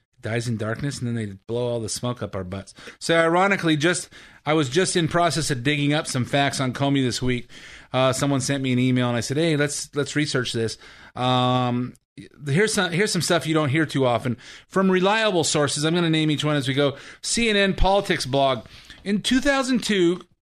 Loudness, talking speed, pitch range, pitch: -22 LUFS, 210 wpm, 125-170 Hz, 145 Hz